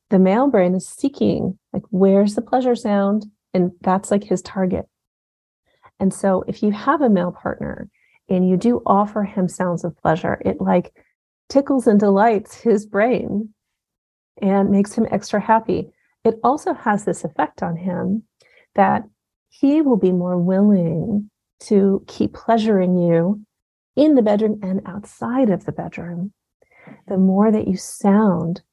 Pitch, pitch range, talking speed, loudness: 205 Hz, 185-225 Hz, 150 wpm, -19 LUFS